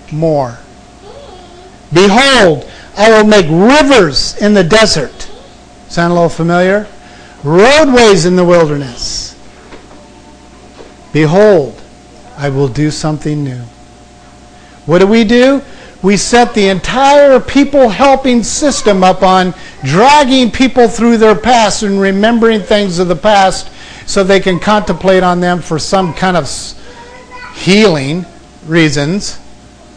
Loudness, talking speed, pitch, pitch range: -9 LUFS, 120 wpm, 195 Hz, 165-230 Hz